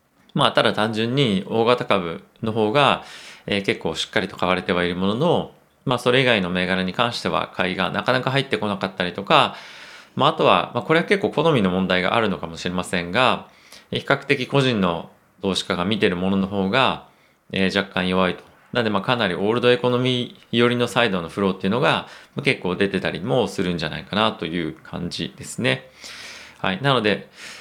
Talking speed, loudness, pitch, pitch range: 390 characters per minute, -21 LUFS, 100 Hz, 90-120 Hz